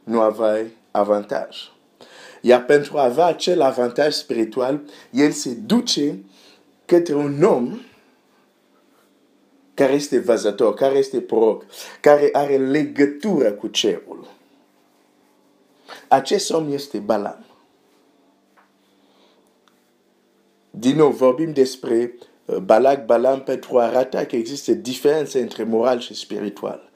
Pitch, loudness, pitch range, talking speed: 140 Hz, -19 LUFS, 120-150 Hz, 105 wpm